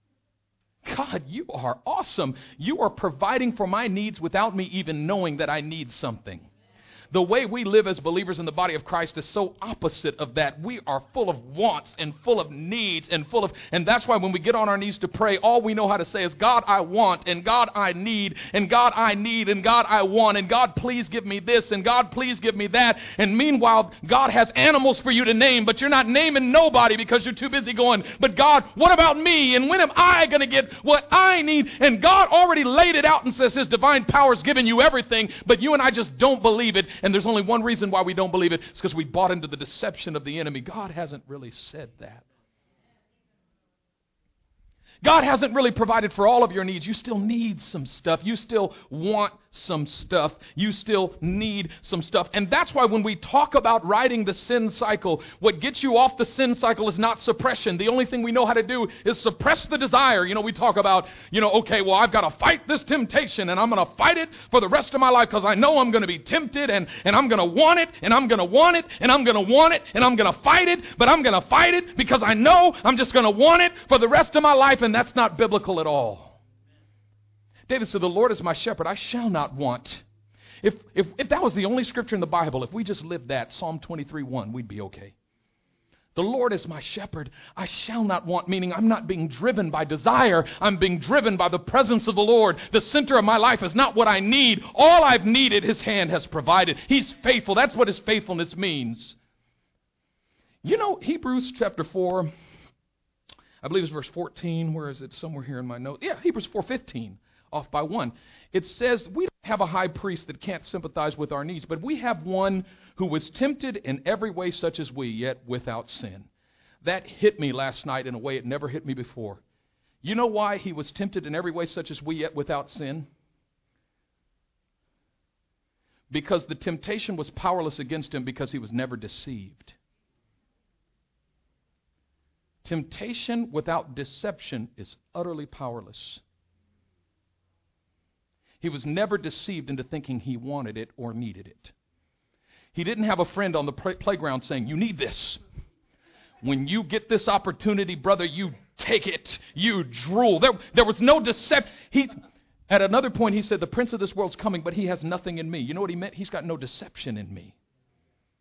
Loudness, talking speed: -21 LUFS, 215 wpm